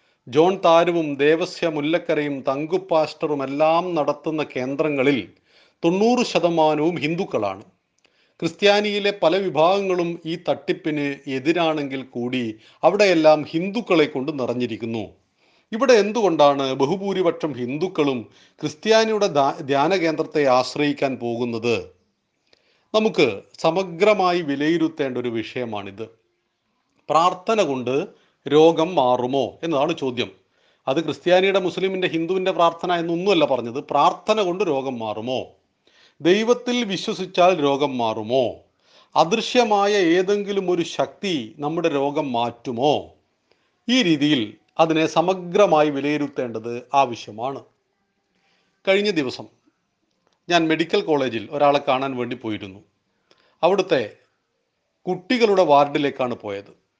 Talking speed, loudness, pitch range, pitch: 85 wpm, -21 LUFS, 130-180 Hz, 155 Hz